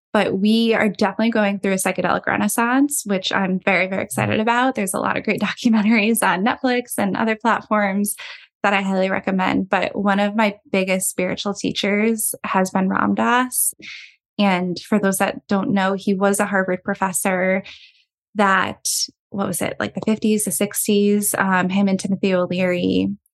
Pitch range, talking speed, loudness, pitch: 190-220 Hz, 170 wpm, -19 LUFS, 200 Hz